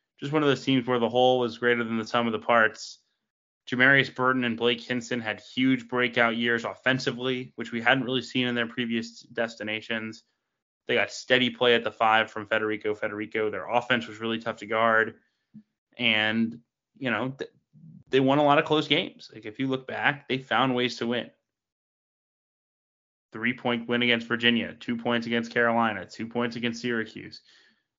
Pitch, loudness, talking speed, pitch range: 120 Hz, -26 LUFS, 180 wpm, 115-125 Hz